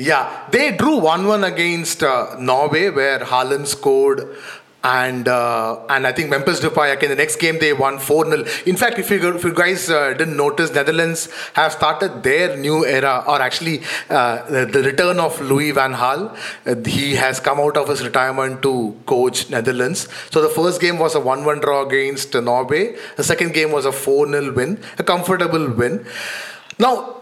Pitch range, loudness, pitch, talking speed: 135-170 Hz, -17 LUFS, 150 Hz, 185 wpm